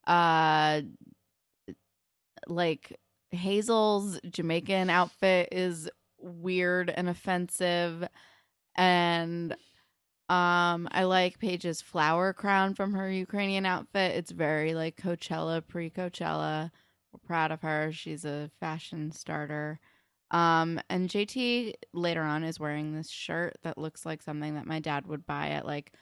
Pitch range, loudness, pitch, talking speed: 155-180 Hz, -30 LUFS, 170 Hz, 125 wpm